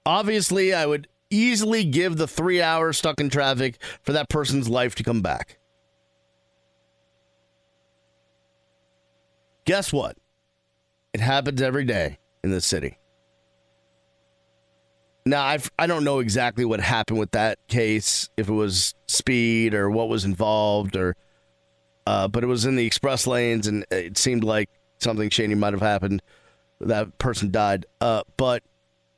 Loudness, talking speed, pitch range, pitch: -23 LUFS, 140 wpm, 110-130 Hz, 115 Hz